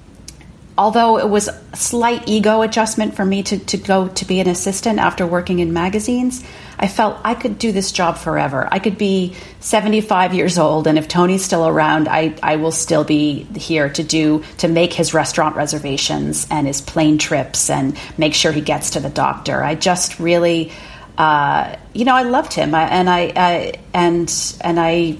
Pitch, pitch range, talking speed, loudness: 175 Hz, 155-200 Hz, 195 wpm, -16 LUFS